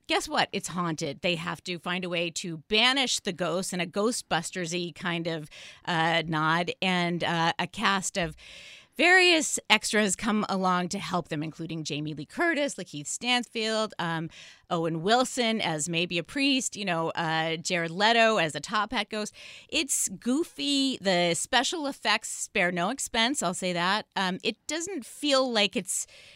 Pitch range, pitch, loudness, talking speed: 170-230 Hz, 190 Hz, -27 LUFS, 165 wpm